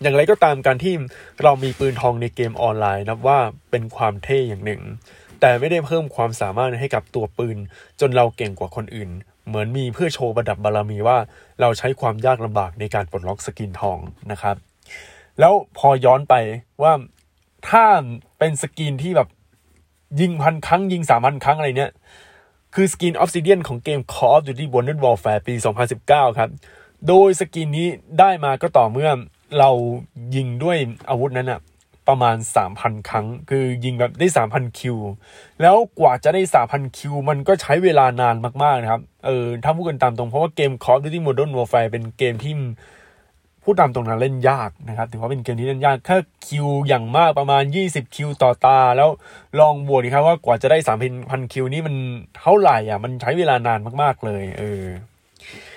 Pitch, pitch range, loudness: 125 Hz, 115-145 Hz, -18 LUFS